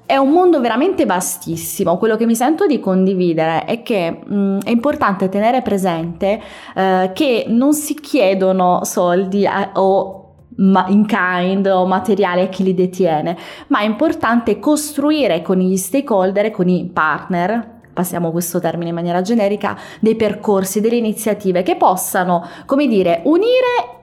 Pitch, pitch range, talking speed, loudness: 195 Hz, 180-230 Hz, 150 wpm, -16 LUFS